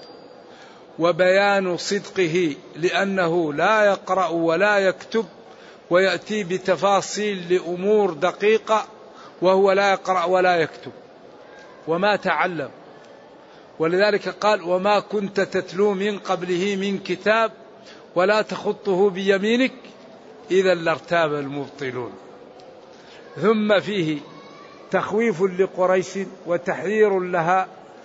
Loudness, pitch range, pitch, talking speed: -21 LUFS, 180-210 Hz, 190 Hz, 85 wpm